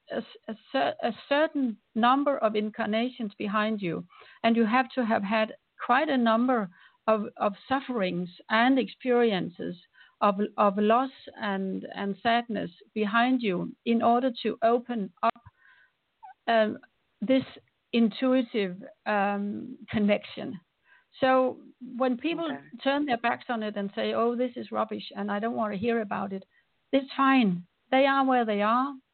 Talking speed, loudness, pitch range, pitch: 145 wpm, -27 LUFS, 210-260 Hz, 230 Hz